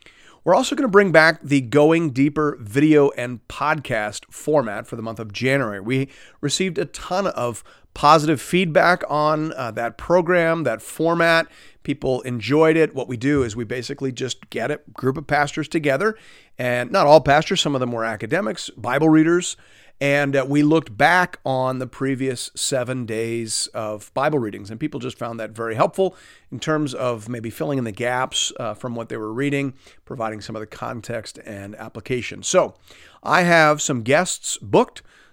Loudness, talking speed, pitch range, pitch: -20 LUFS, 180 wpm, 120-155 Hz, 135 Hz